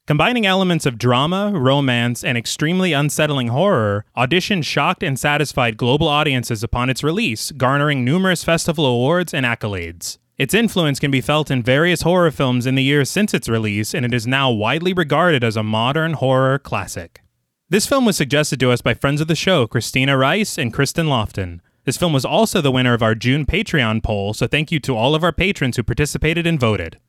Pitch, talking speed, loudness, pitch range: 140 Hz, 195 wpm, -17 LUFS, 120-165 Hz